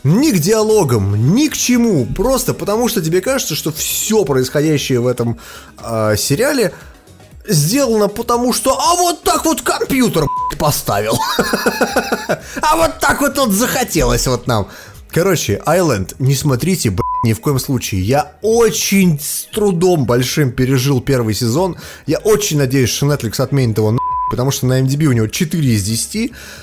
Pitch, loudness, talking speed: 155 Hz, -15 LUFS, 150 wpm